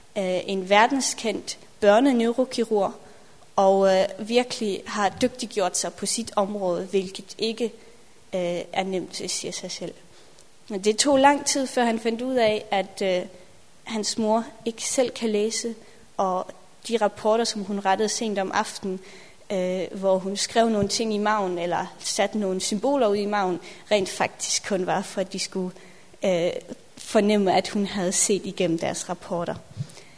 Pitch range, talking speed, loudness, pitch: 190-225 Hz, 155 wpm, -24 LUFS, 205 Hz